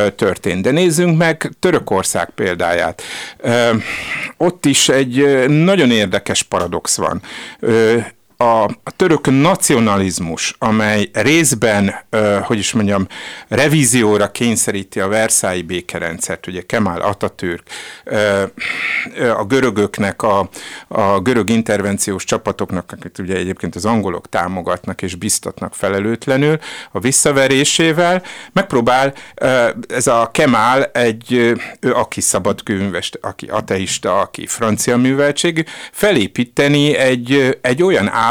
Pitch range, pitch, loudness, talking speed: 100-140 Hz, 115 Hz, -15 LUFS, 110 wpm